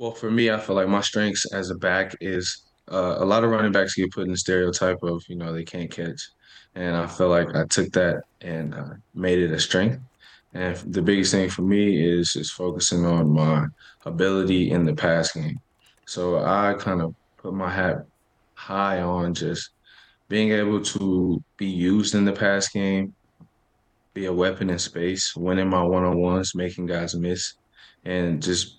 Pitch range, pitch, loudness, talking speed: 85-100 Hz, 90 Hz, -23 LUFS, 190 wpm